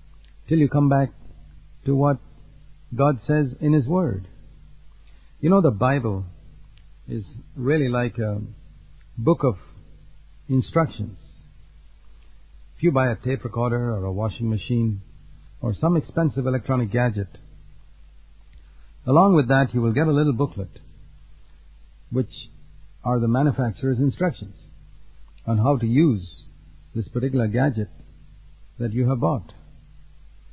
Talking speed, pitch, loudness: 120 wpm, 120 Hz, -23 LUFS